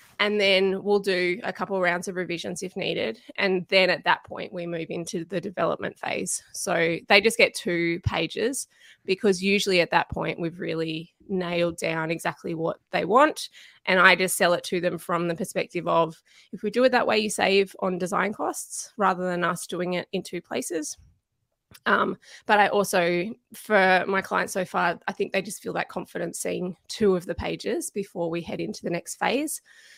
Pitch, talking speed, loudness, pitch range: 185 Hz, 200 wpm, -25 LUFS, 175-200 Hz